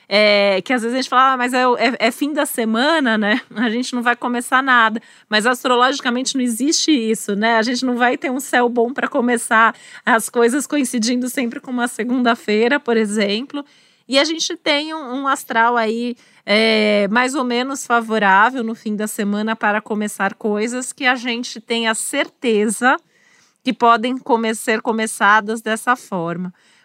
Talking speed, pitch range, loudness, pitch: 180 wpm, 220-255 Hz, -17 LUFS, 240 Hz